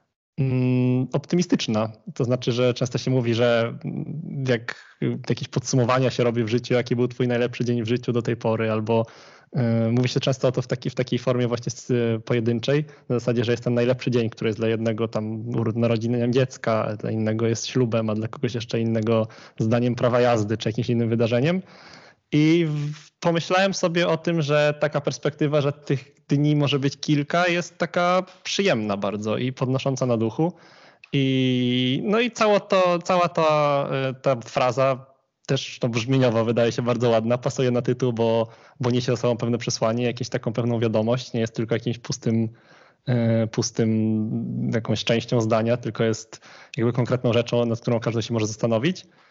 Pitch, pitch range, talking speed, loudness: 125 Hz, 115-140 Hz, 175 wpm, -23 LUFS